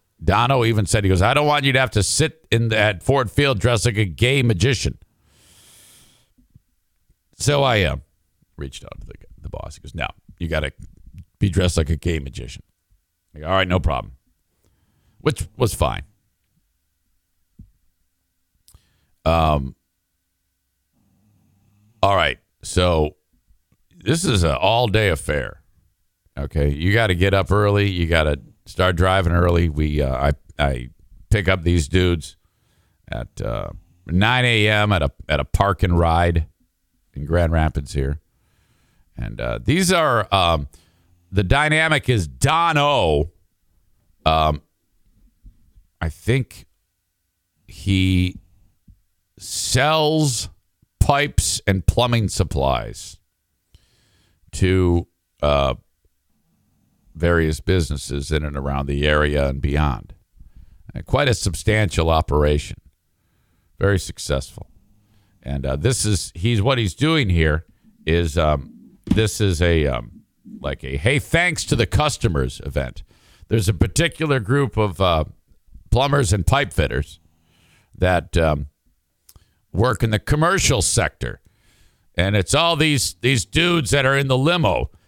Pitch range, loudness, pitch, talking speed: 80-105 Hz, -19 LUFS, 90 Hz, 130 wpm